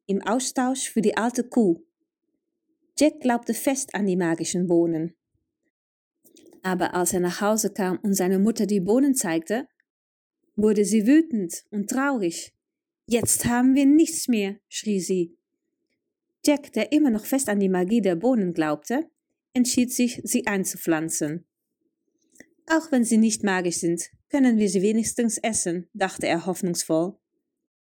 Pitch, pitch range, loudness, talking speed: 230 Hz, 185-295 Hz, -23 LUFS, 140 wpm